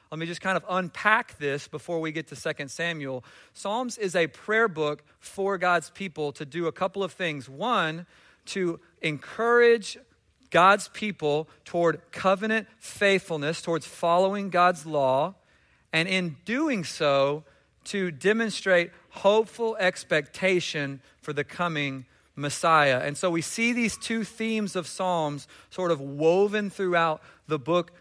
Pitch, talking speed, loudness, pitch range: 175 Hz, 140 wpm, -26 LUFS, 155-195 Hz